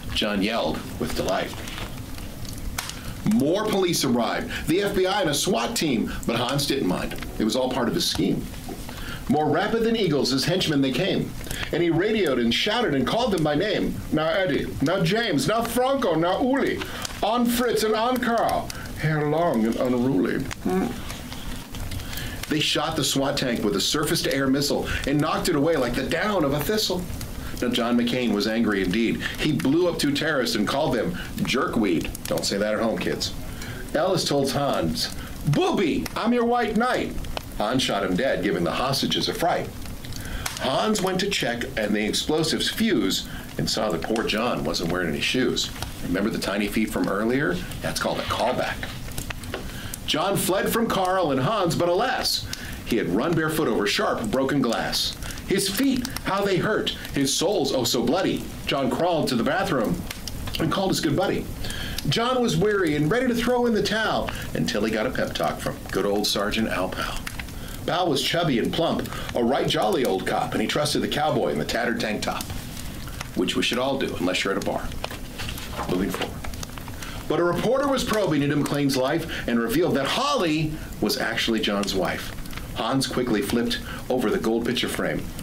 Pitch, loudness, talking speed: 150 Hz, -24 LUFS, 180 wpm